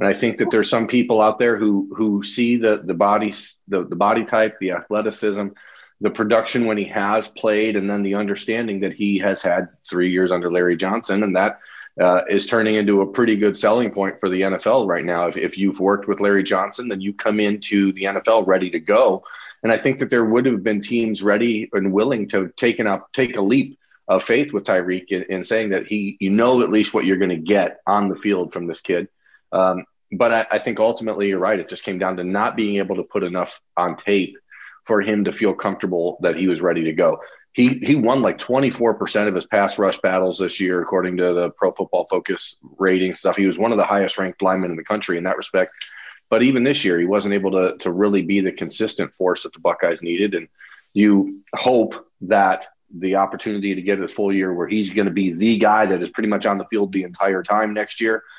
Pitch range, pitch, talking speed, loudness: 95-110 Hz, 100 Hz, 235 wpm, -19 LUFS